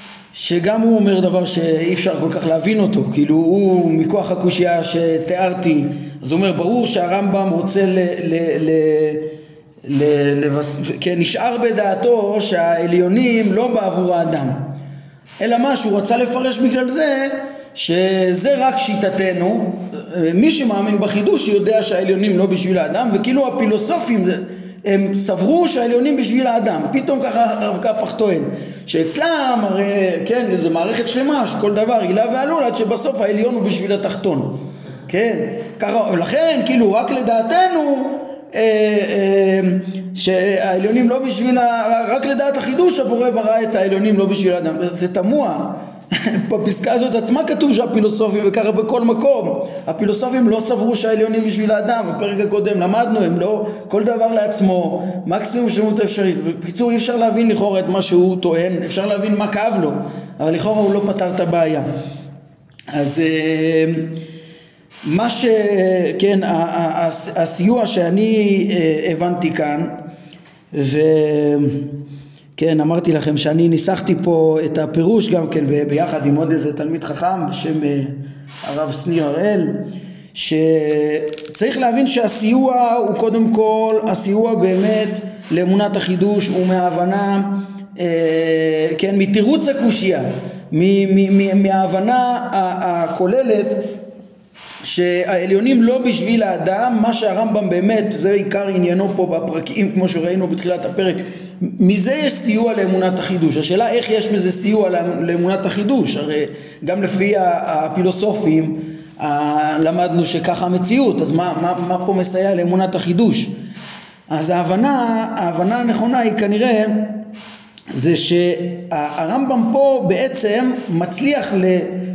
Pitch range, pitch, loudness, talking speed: 170-225 Hz, 195 Hz, -16 LUFS, 125 wpm